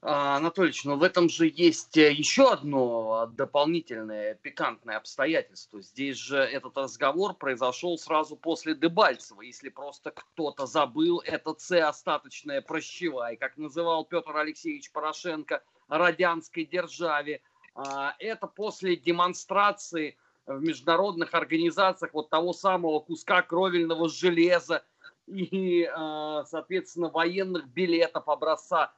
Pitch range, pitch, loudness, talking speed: 150-180 Hz, 165 Hz, -27 LUFS, 105 wpm